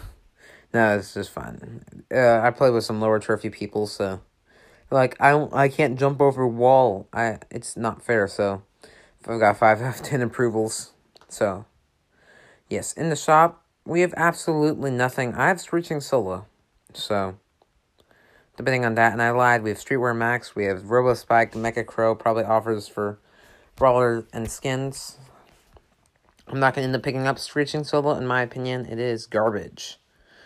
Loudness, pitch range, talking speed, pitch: -22 LUFS, 105-135 Hz, 165 wpm, 120 Hz